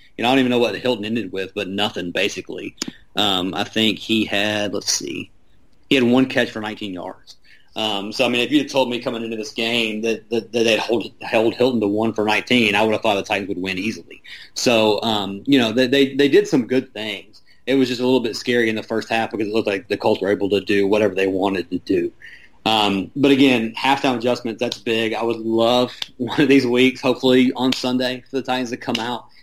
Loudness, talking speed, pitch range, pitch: -19 LUFS, 245 wpm, 105-130 Hz, 115 Hz